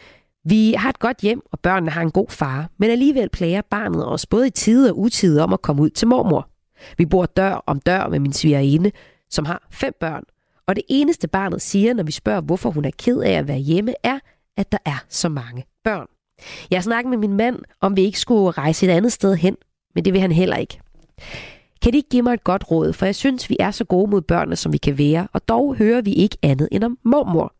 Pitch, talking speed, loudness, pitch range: 195 Hz, 245 wpm, -19 LUFS, 165-230 Hz